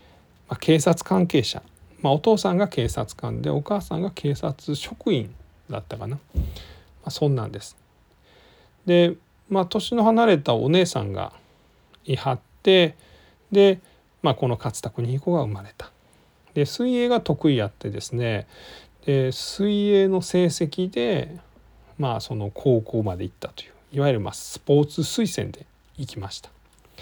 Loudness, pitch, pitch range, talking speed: -23 LUFS, 140 Hz, 110-180 Hz, 265 characters per minute